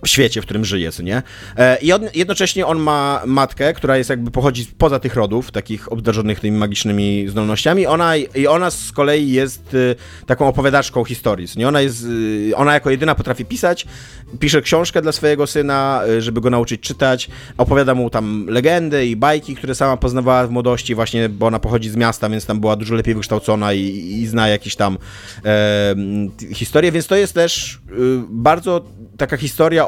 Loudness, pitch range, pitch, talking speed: -16 LUFS, 110-140 Hz, 125 Hz, 180 wpm